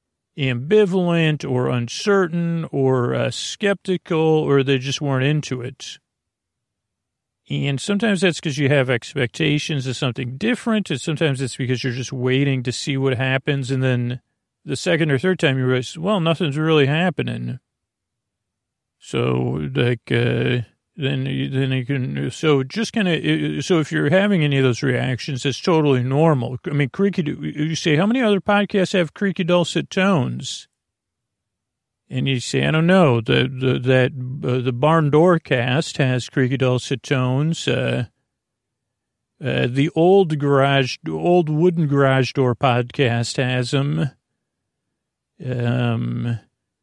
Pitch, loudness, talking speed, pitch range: 135 Hz, -20 LUFS, 145 wpm, 125-160 Hz